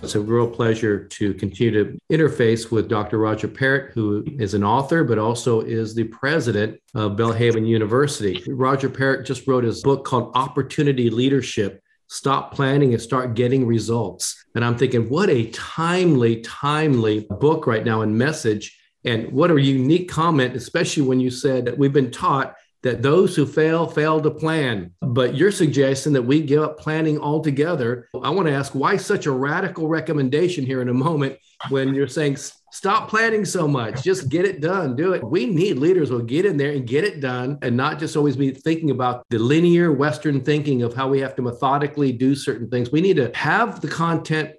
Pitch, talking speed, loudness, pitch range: 135 Hz, 190 wpm, -20 LUFS, 120-155 Hz